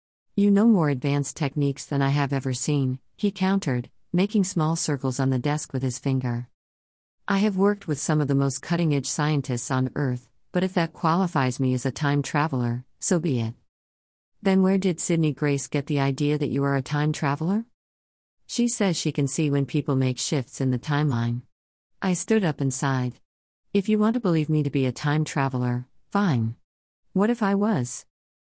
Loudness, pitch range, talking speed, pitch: -24 LUFS, 130-170 Hz, 195 wpm, 145 Hz